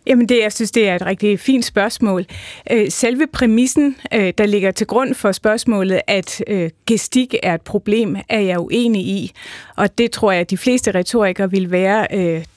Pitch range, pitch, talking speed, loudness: 190-235 Hz, 210 Hz, 175 wpm, -16 LUFS